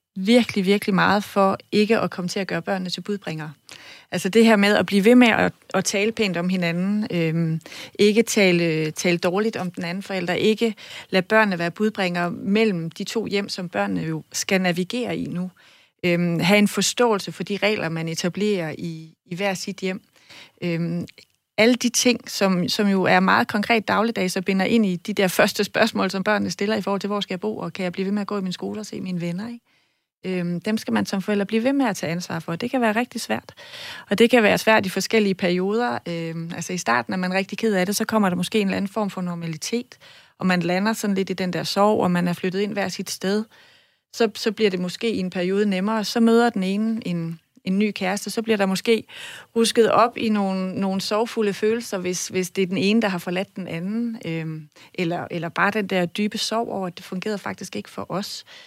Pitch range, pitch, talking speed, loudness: 180-220 Hz, 195 Hz, 230 wpm, -22 LUFS